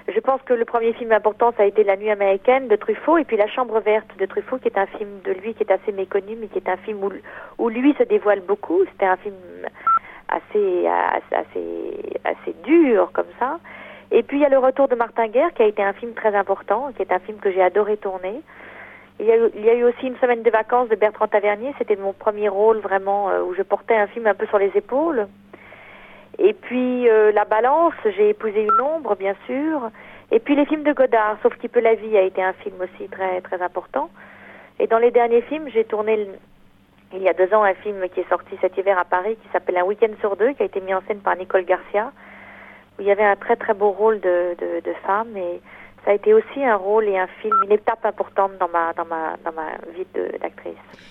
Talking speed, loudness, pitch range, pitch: 245 wpm, -20 LUFS, 195-250 Hz, 215 Hz